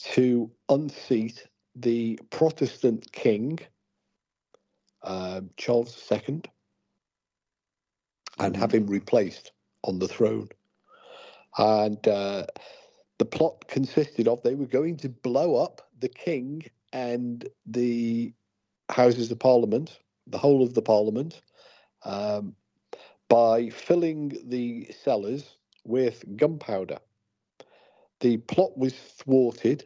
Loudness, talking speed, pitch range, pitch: -26 LUFS, 100 wpm, 110-135 Hz, 120 Hz